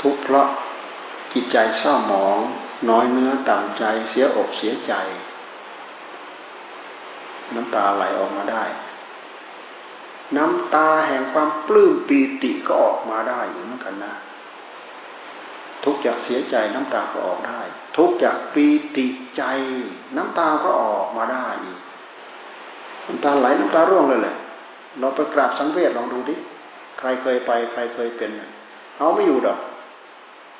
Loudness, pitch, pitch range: -20 LUFS, 140 Hz, 130-155 Hz